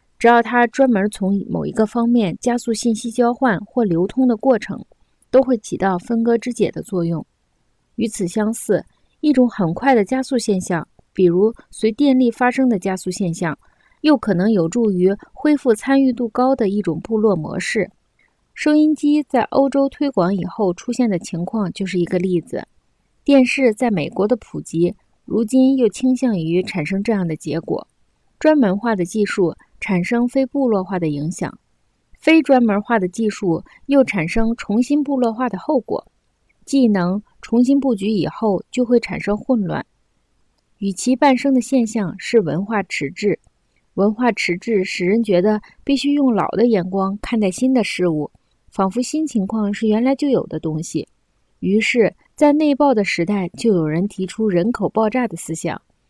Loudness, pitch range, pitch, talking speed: -18 LUFS, 190-250 Hz, 220 Hz, 250 characters per minute